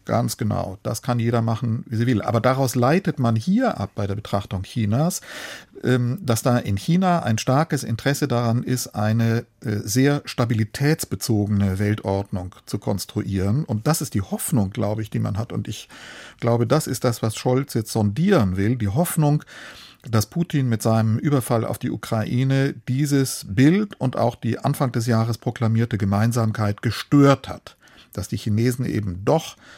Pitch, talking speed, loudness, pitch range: 115 Hz, 165 wpm, -22 LUFS, 110-135 Hz